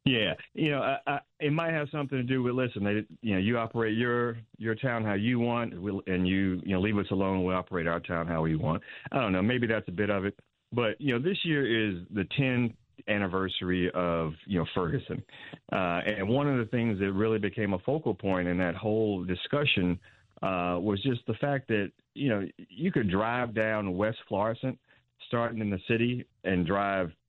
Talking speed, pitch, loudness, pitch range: 205 wpm, 105 Hz, -30 LUFS, 95-120 Hz